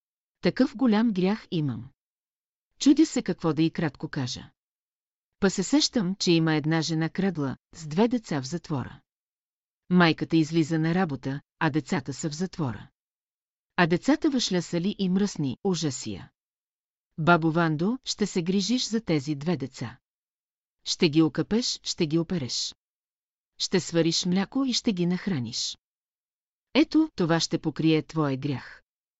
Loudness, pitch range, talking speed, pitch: -26 LUFS, 155-195 Hz, 140 wpm, 170 Hz